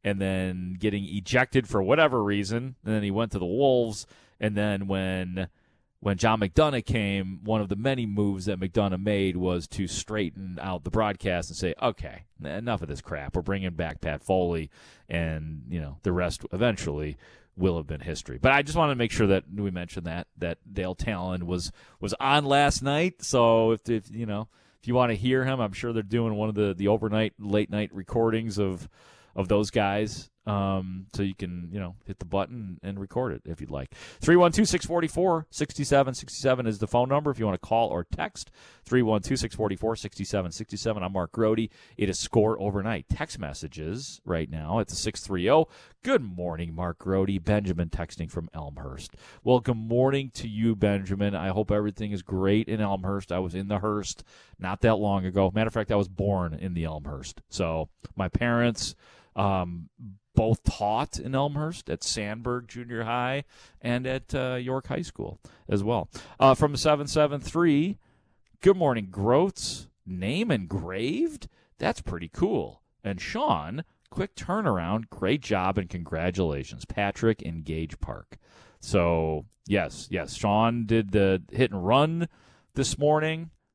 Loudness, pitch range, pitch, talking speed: -27 LUFS, 95-120 Hz, 105 Hz, 170 wpm